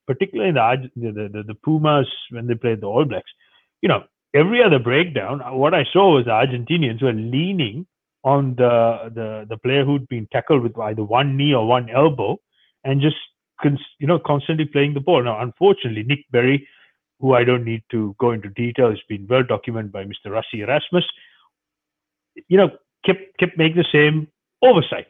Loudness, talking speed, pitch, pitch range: -19 LUFS, 185 wpm, 135 Hz, 115-155 Hz